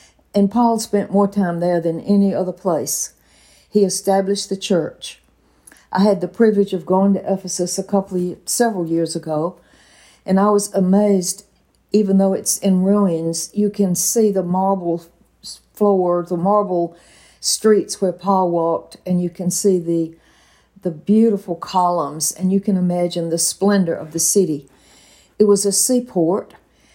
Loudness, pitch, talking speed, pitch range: -18 LUFS, 190 Hz, 155 wpm, 170-200 Hz